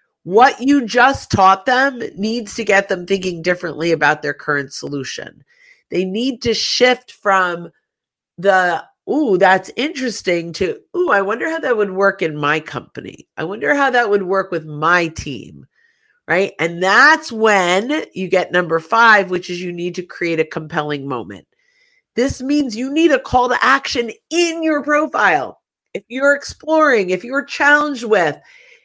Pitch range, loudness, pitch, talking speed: 180-280 Hz, -16 LUFS, 210 Hz, 165 wpm